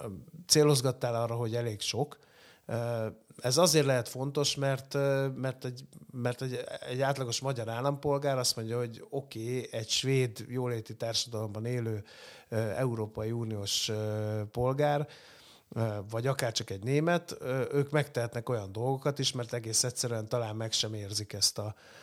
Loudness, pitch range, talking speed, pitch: -31 LUFS, 110-135 Hz, 135 wpm, 120 Hz